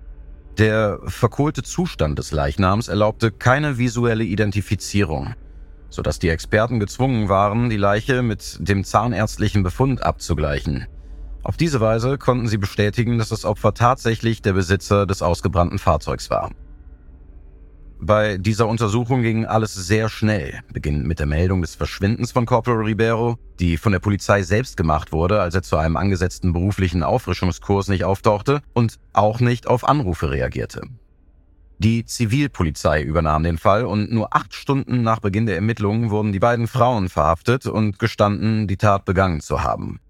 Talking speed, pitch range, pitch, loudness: 150 wpm, 85-115 Hz, 100 Hz, -20 LUFS